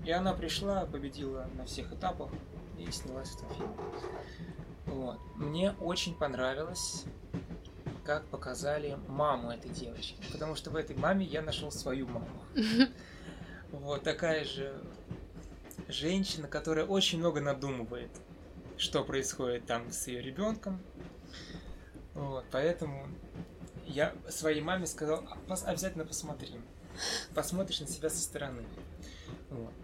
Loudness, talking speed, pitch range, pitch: -36 LUFS, 115 wpm, 130-170 Hz, 150 Hz